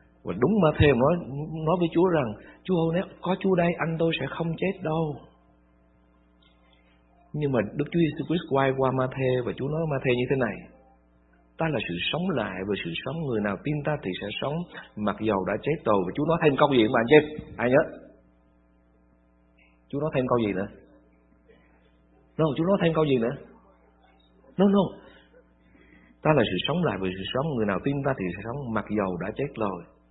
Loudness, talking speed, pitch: -26 LUFS, 210 wpm, 115 Hz